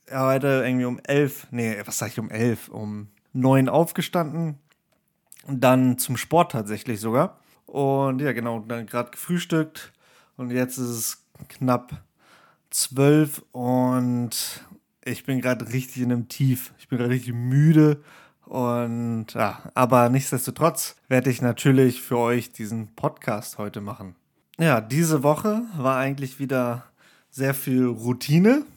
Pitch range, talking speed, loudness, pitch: 120-145 Hz, 140 wpm, -23 LUFS, 130 Hz